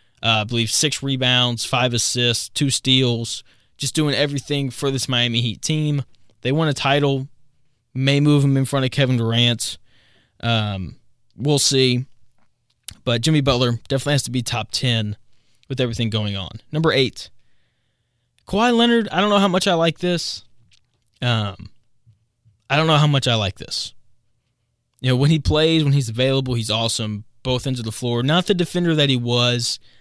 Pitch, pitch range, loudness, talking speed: 125 Hz, 115-140 Hz, -19 LUFS, 175 wpm